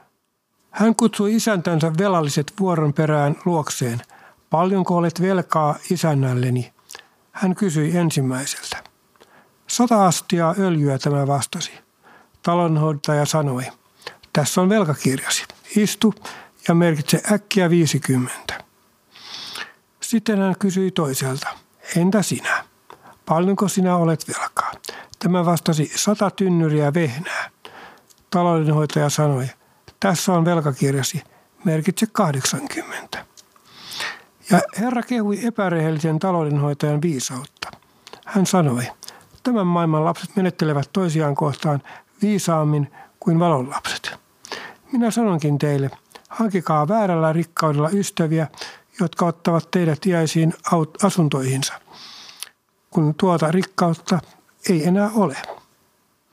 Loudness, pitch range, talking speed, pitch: -20 LUFS, 150-190 Hz, 95 wpm, 170 Hz